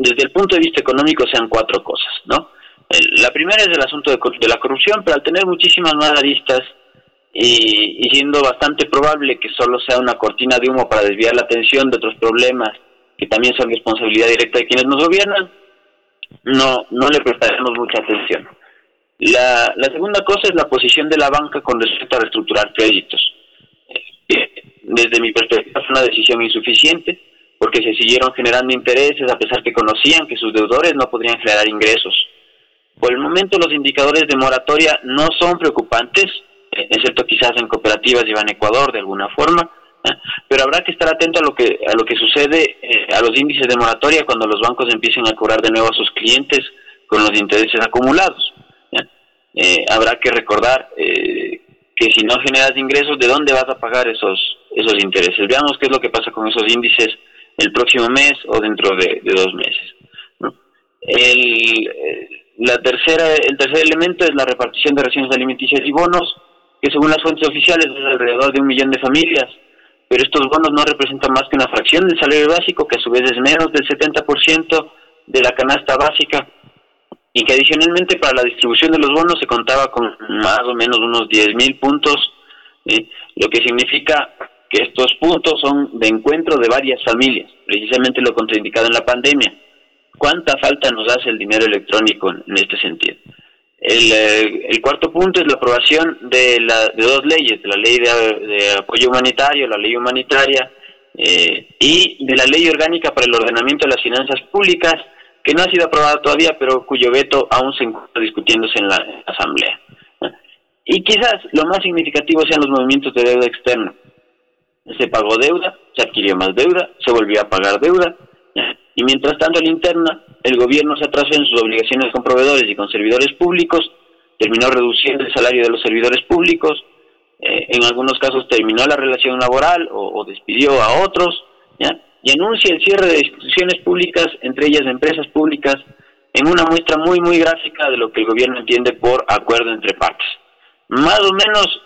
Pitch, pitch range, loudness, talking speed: 140 Hz, 125-175 Hz, -13 LUFS, 185 wpm